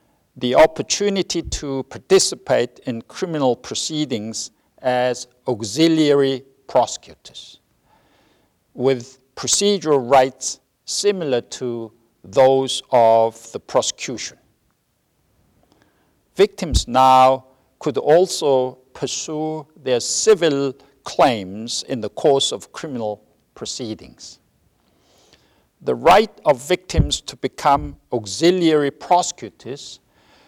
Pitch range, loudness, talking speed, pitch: 125-155 Hz, -19 LUFS, 80 wpm, 130 Hz